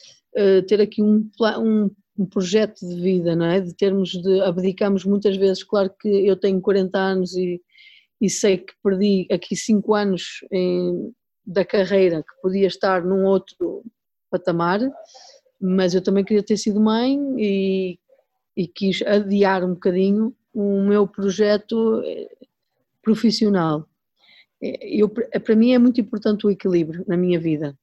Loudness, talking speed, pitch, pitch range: -20 LUFS, 140 wpm, 200 Hz, 185-215 Hz